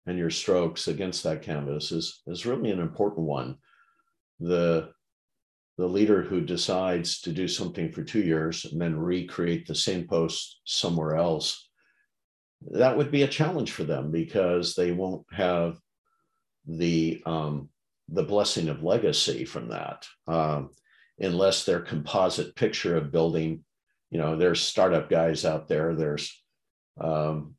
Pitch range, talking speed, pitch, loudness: 80-95 Hz, 145 wpm, 85 Hz, -27 LUFS